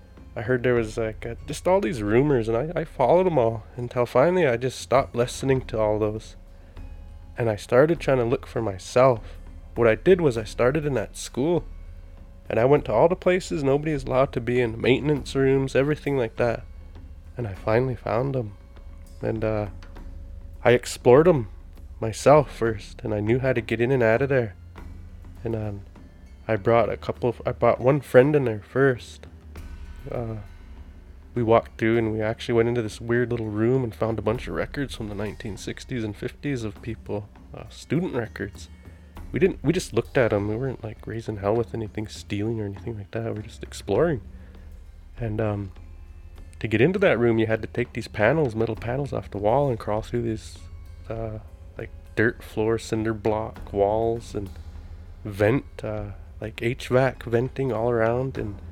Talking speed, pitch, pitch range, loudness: 190 wpm, 110 Hz, 90-120 Hz, -24 LUFS